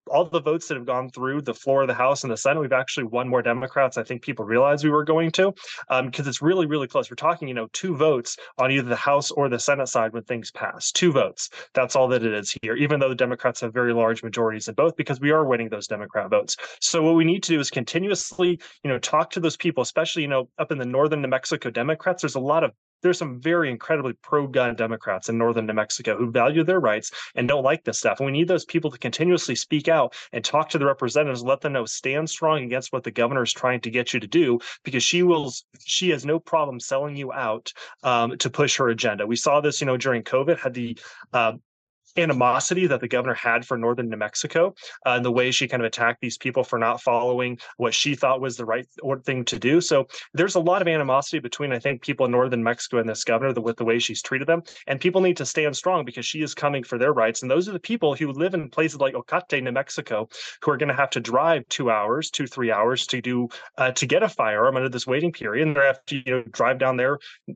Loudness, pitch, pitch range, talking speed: -23 LUFS, 135 Hz, 125-155 Hz, 260 wpm